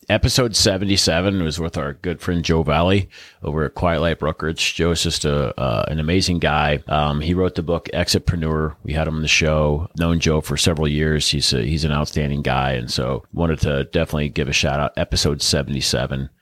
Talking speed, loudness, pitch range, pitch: 205 wpm, -19 LUFS, 75-85 Hz, 80 Hz